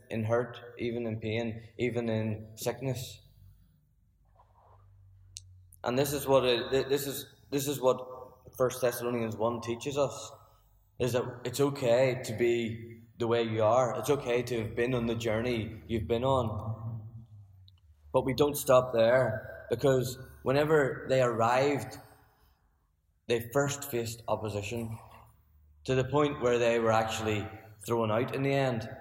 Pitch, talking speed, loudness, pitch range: 115 Hz, 145 wpm, -30 LUFS, 110-130 Hz